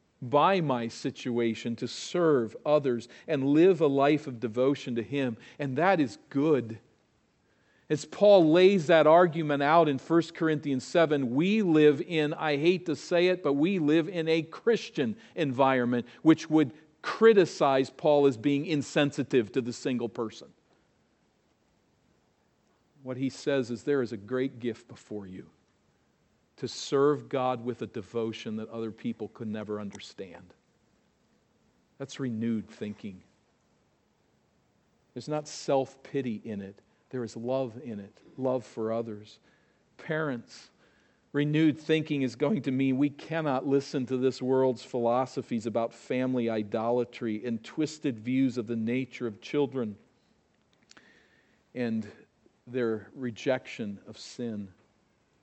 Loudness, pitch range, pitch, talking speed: -28 LUFS, 115-150 Hz, 130 Hz, 135 wpm